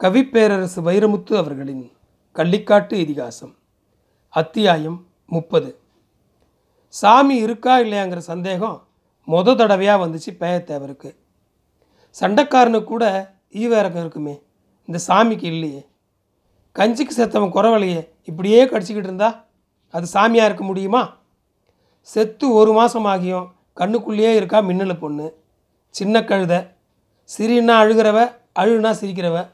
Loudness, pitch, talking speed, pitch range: -17 LUFS, 195 Hz, 95 wpm, 160-220 Hz